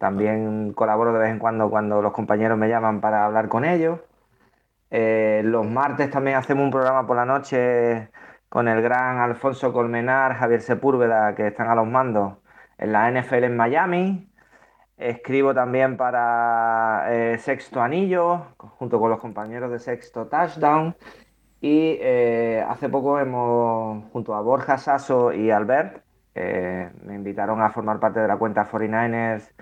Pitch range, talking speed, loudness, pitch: 110-130 Hz, 155 wpm, -22 LUFS, 120 Hz